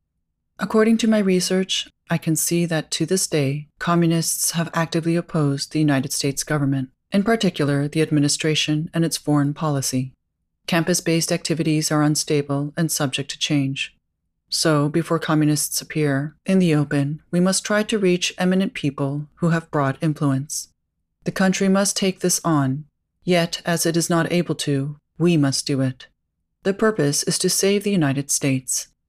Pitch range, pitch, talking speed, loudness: 145-175 Hz, 155 Hz, 165 wpm, -21 LUFS